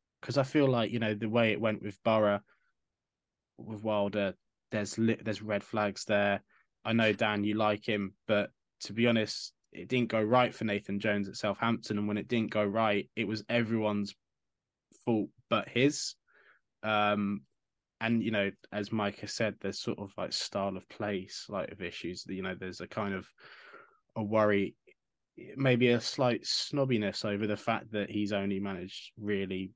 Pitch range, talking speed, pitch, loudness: 100-115 Hz, 180 wpm, 105 Hz, -32 LUFS